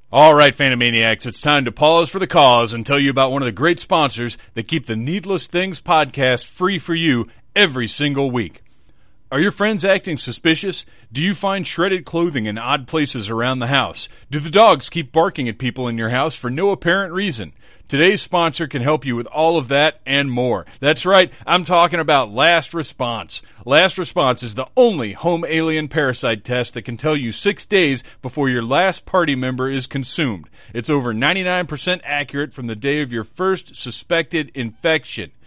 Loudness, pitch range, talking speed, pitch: -17 LUFS, 125-170 Hz, 190 wpm, 145 Hz